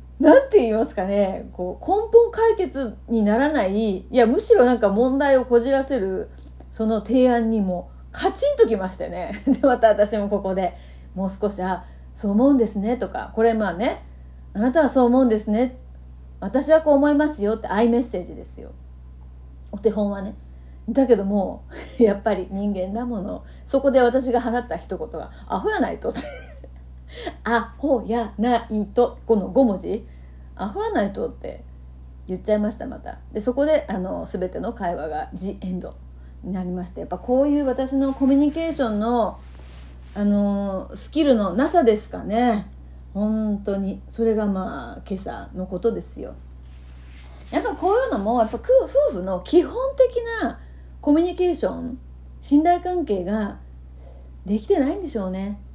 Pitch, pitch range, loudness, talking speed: 215 Hz, 185-265 Hz, -21 LUFS, 310 characters per minute